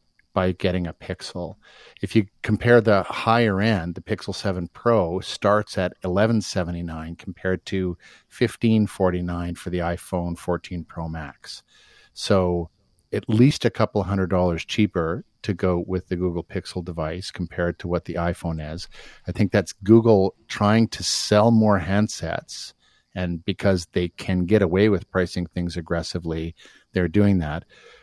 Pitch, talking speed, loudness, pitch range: 95 Hz, 150 wpm, -23 LUFS, 85-105 Hz